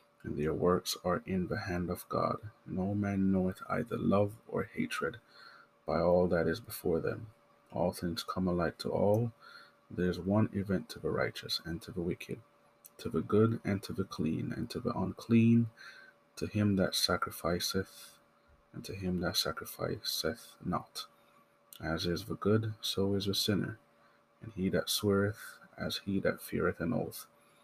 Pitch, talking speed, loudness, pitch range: 95 Hz, 170 wpm, -34 LUFS, 90-105 Hz